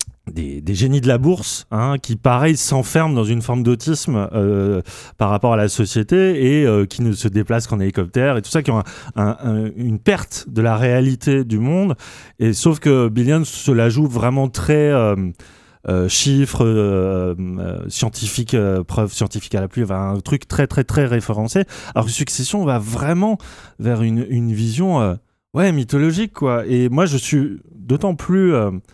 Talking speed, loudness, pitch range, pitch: 185 wpm, -18 LUFS, 105-140 Hz, 120 Hz